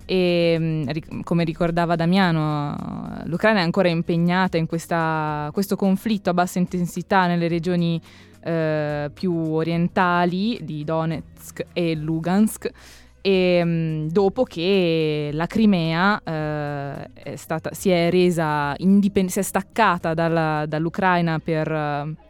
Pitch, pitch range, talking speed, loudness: 170 Hz, 160-185 Hz, 115 wpm, -21 LUFS